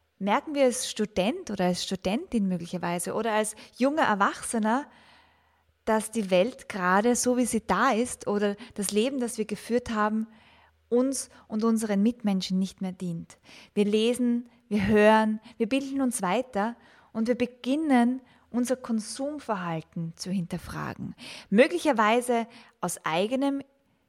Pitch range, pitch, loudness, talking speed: 205-245 Hz, 225 Hz, -27 LUFS, 130 wpm